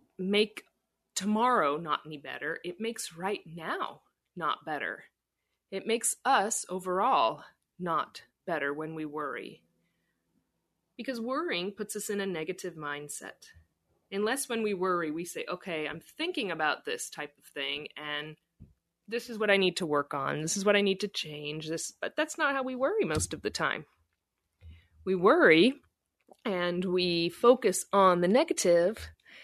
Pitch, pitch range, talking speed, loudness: 180 Hz, 155-215 Hz, 155 wpm, -30 LUFS